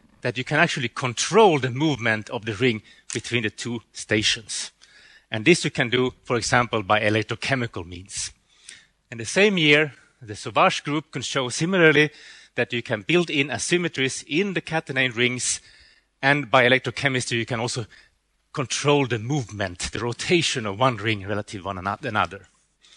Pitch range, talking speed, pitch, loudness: 115-145 Hz, 160 wpm, 125 Hz, -22 LUFS